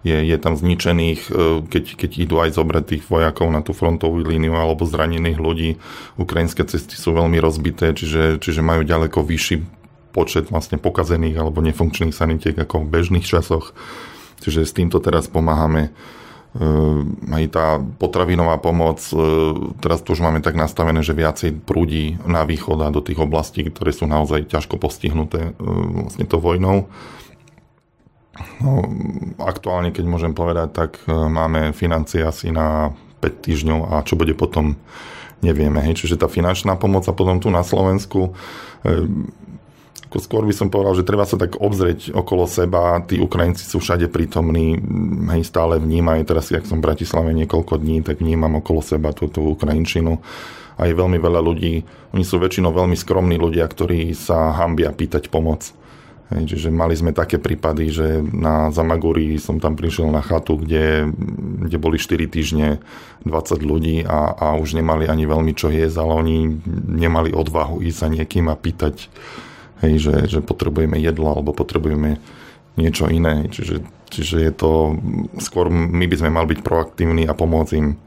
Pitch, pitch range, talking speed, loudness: 80 Hz, 80-85 Hz, 160 wpm, -19 LUFS